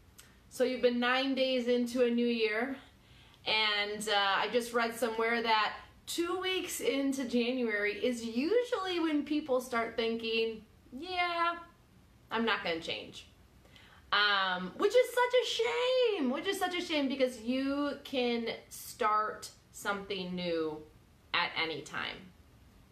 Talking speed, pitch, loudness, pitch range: 135 wpm, 245 Hz, -32 LUFS, 220-300 Hz